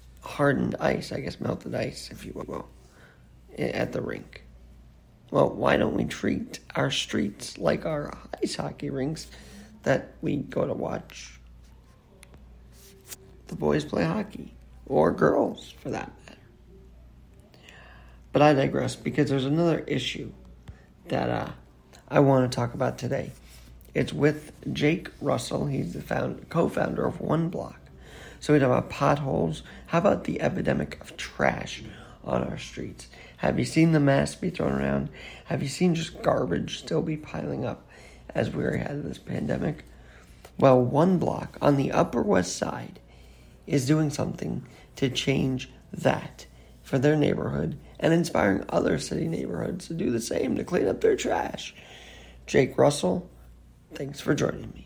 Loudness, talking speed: -27 LUFS, 150 wpm